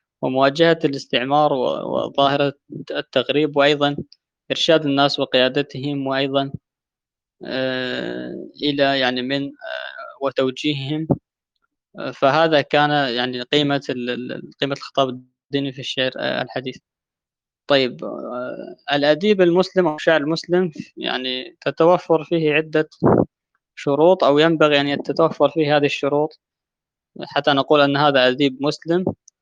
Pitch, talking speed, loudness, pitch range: 140 Hz, 100 wpm, -19 LUFS, 135-155 Hz